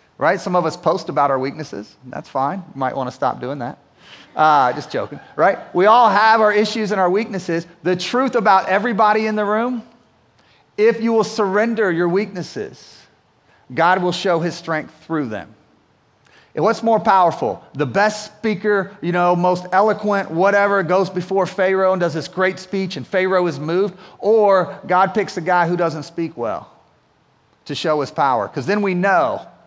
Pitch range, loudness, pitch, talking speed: 170-210 Hz, -18 LUFS, 185 Hz, 180 wpm